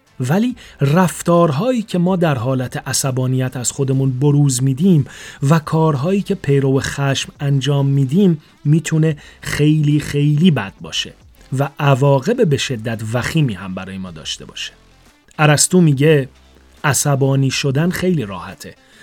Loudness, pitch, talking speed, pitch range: -16 LUFS, 140 Hz, 125 wpm, 135-160 Hz